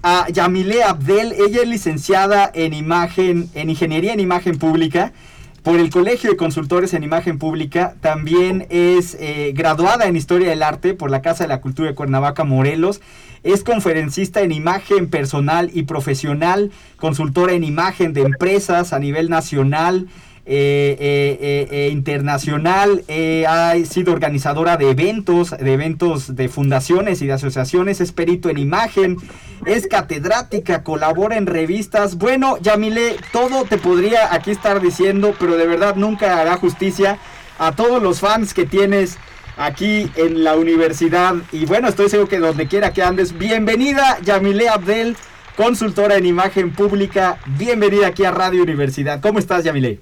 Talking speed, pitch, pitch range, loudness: 150 wpm, 175 Hz, 155-200 Hz, -16 LUFS